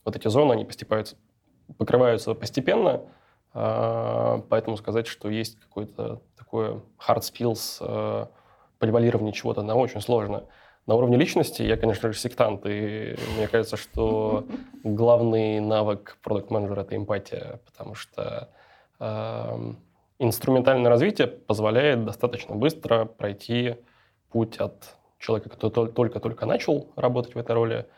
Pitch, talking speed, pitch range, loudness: 115 Hz, 120 wpm, 105-120 Hz, -25 LUFS